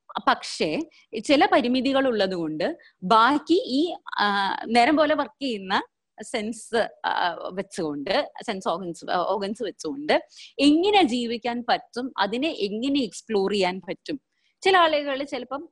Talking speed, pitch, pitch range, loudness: 105 wpm, 255 Hz, 205-305 Hz, -24 LUFS